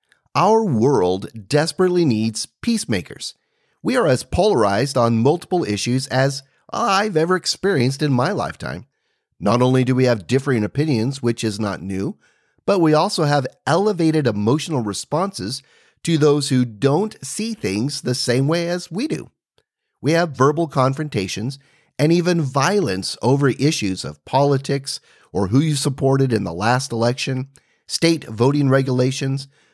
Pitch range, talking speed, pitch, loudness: 120-160 Hz, 145 wpm, 135 Hz, -19 LUFS